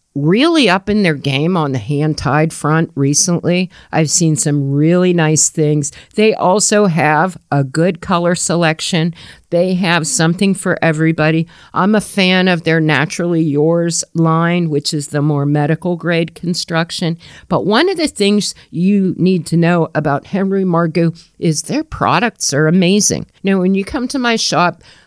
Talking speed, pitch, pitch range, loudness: 165 wpm, 170 Hz, 155-185 Hz, -14 LUFS